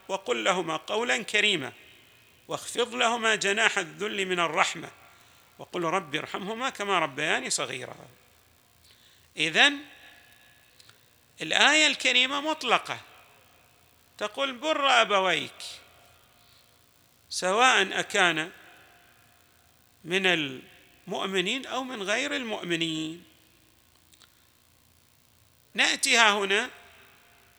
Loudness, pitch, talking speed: -25 LUFS, 195 Hz, 70 wpm